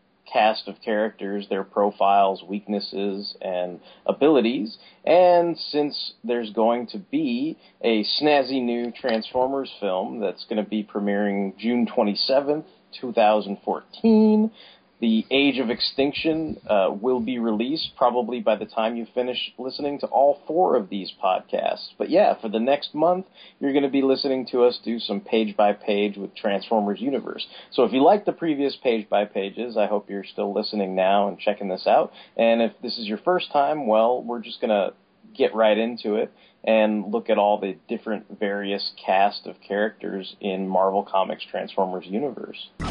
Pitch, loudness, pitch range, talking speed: 115 Hz, -23 LUFS, 100-135 Hz, 165 wpm